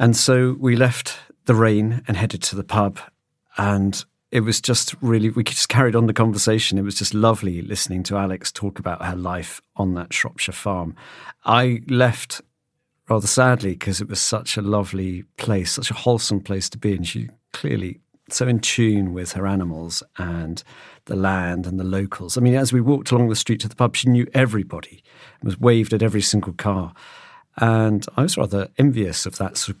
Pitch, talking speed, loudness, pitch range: 105 Hz, 200 wpm, -20 LUFS, 95-120 Hz